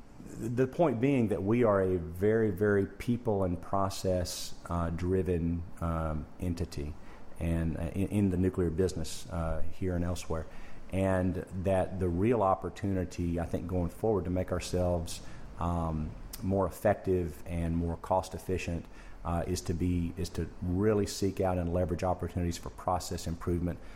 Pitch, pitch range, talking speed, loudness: 90 Hz, 85-95 Hz, 155 wpm, -32 LUFS